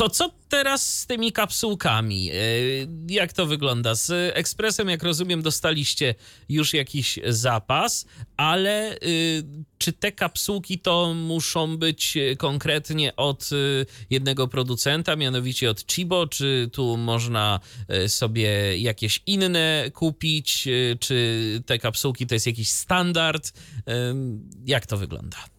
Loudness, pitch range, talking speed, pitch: -23 LUFS, 120-165 Hz, 115 wpm, 140 Hz